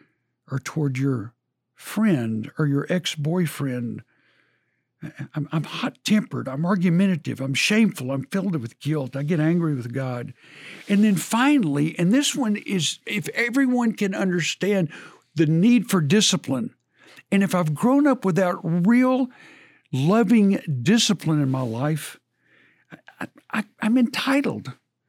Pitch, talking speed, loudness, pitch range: 175 Hz, 135 wpm, -22 LUFS, 140-210 Hz